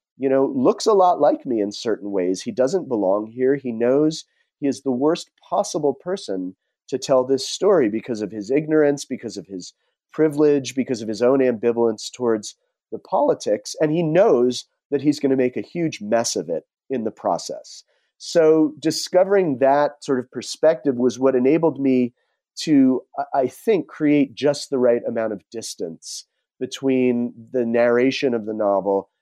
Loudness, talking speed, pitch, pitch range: -20 LUFS, 175 wpm, 130 Hz, 120-150 Hz